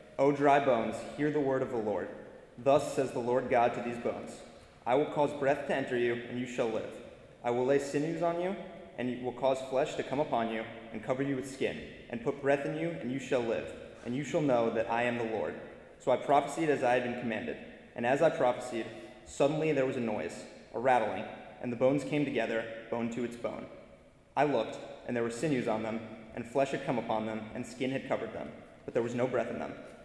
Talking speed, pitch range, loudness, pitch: 240 wpm, 115-140 Hz, -32 LUFS, 125 Hz